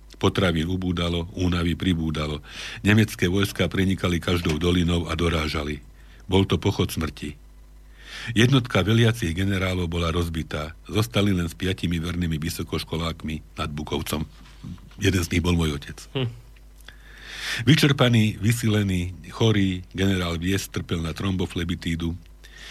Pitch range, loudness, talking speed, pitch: 80-100 Hz, -24 LUFS, 110 wpm, 90 Hz